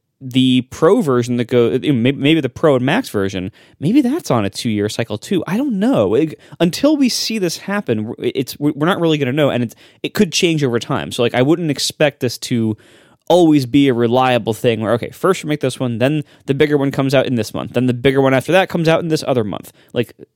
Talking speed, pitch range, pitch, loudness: 235 wpm, 120-160 Hz, 135 Hz, -16 LUFS